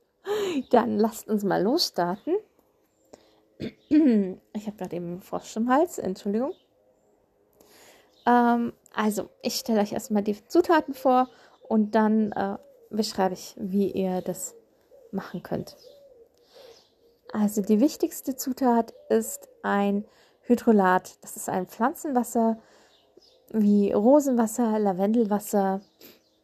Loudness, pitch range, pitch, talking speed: -25 LUFS, 205-285 Hz, 230 Hz, 105 wpm